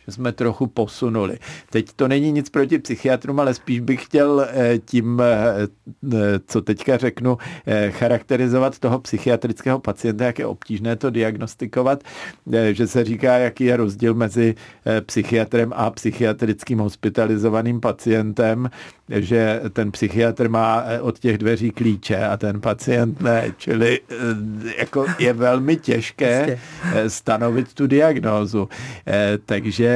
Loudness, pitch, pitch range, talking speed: -20 LUFS, 115 Hz, 110-125 Hz, 120 wpm